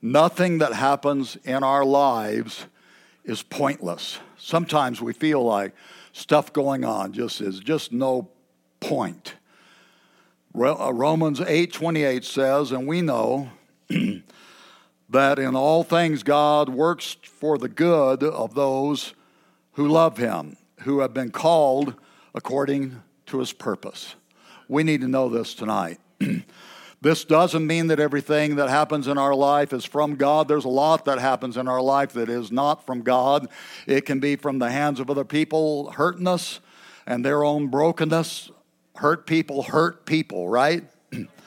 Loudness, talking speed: -22 LUFS, 145 wpm